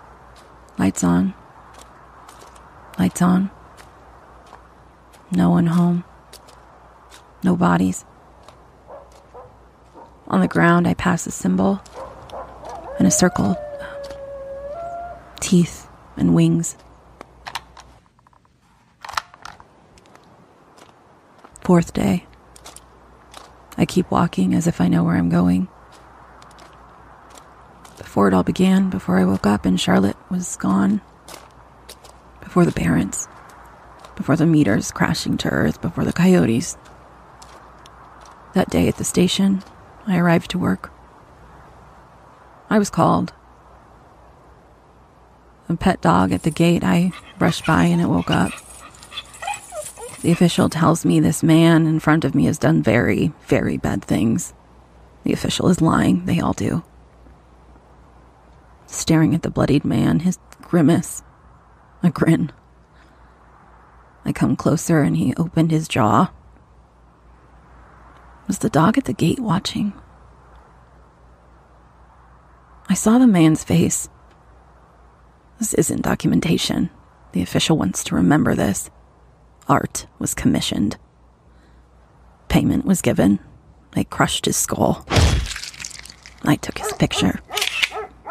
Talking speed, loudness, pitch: 105 wpm, -19 LUFS, 95 Hz